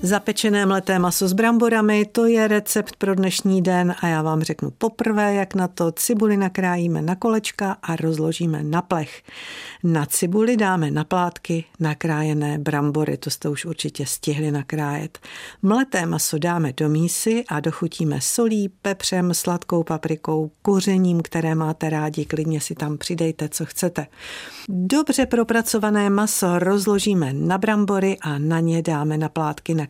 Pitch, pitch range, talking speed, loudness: 175 Hz, 155-205 Hz, 145 wpm, -21 LUFS